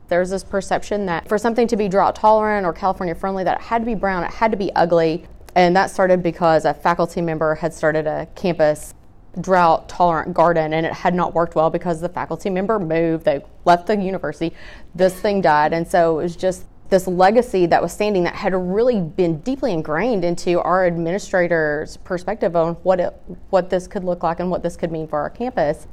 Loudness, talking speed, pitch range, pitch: -19 LUFS, 215 wpm, 165-195 Hz, 175 Hz